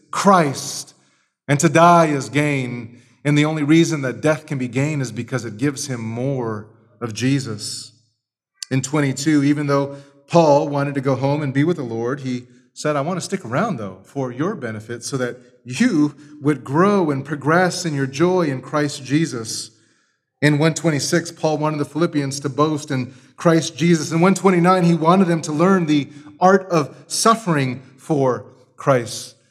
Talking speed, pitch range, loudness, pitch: 175 wpm, 130-160 Hz, -19 LUFS, 145 Hz